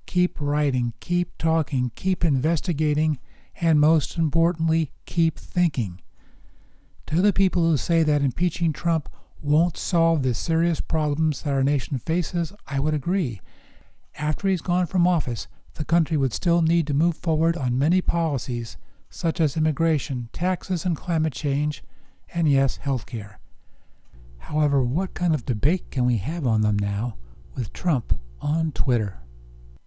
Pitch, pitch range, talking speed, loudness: 155 Hz, 130-170 Hz, 145 wpm, -24 LUFS